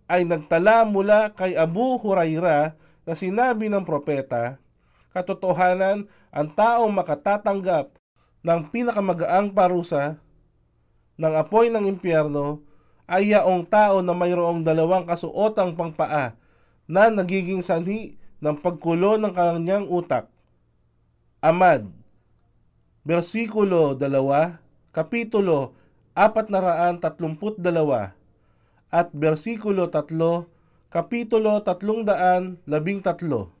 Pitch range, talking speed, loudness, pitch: 150-200 Hz, 90 wpm, -22 LUFS, 175 Hz